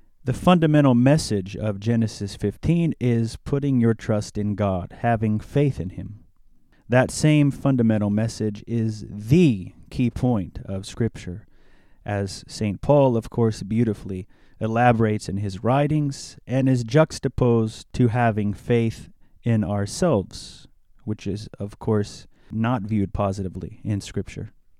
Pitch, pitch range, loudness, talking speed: 110 Hz, 100-125 Hz, -23 LUFS, 130 wpm